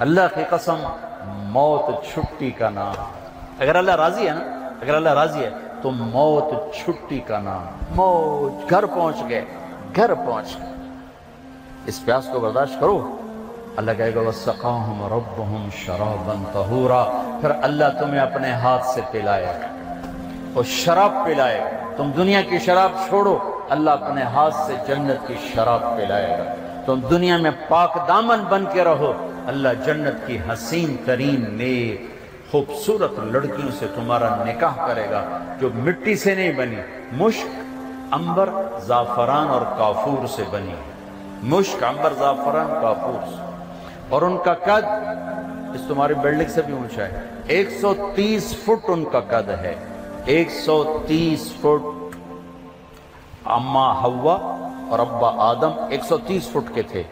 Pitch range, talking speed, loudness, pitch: 110-175 Hz, 140 wpm, -21 LUFS, 135 Hz